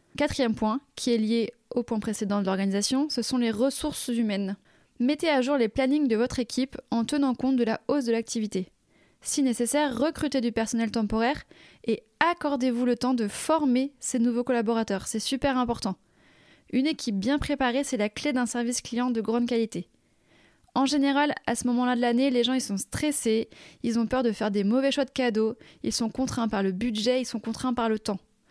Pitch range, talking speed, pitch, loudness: 225-265 Hz, 200 wpm, 245 Hz, -27 LUFS